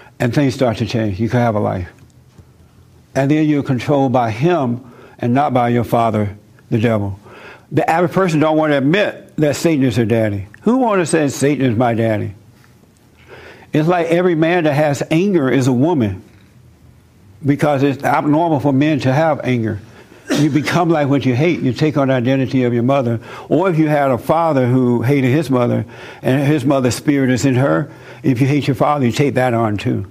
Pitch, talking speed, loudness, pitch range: 130 Hz, 205 wpm, -16 LUFS, 120-150 Hz